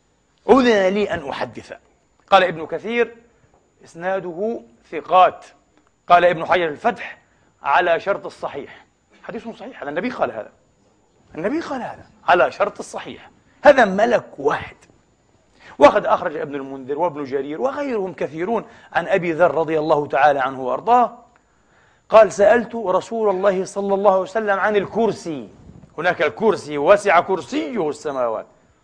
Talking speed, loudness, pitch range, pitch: 125 wpm, -19 LUFS, 165-220 Hz, 190 Hz